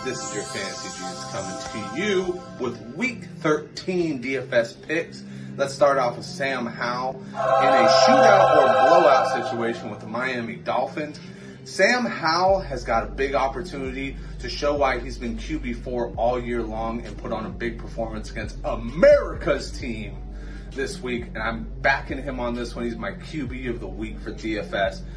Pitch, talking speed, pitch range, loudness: 125 Hz, 170 wpm, 115-150 Hz, -23 LUFS